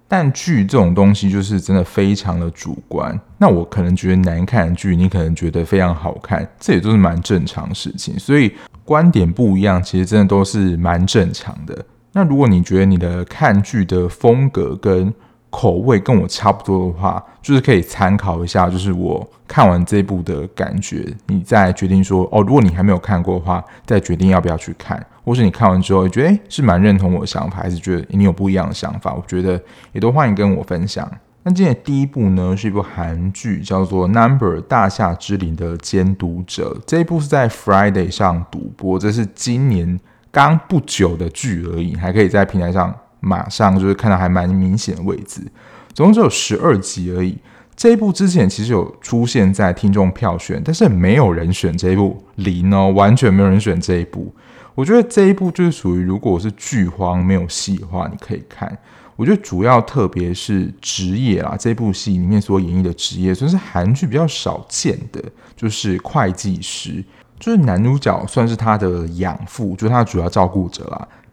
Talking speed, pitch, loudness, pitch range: 310 characters per minute, 95 Hz, -16 LUFS, 90-110 Hz